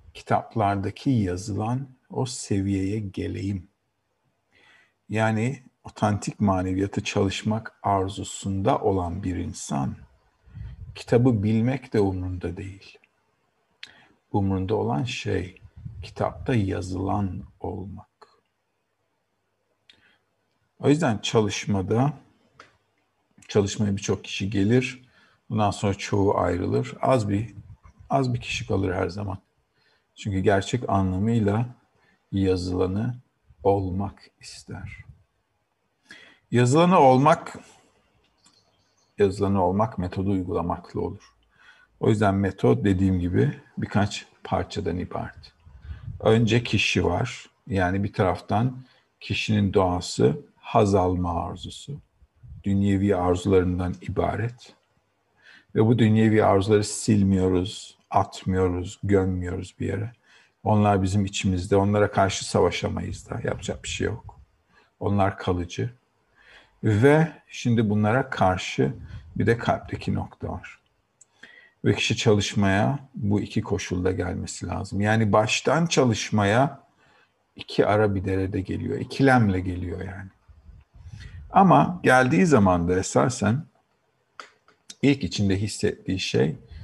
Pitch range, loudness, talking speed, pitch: 95-115 Hz, -24 LUFS, 95 wpm, 100 Hz